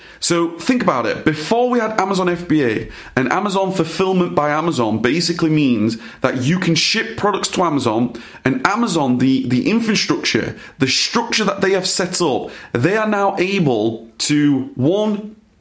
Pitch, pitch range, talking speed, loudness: 170 Hz, 135-195 Hz, 160 wpm, -17 LUFS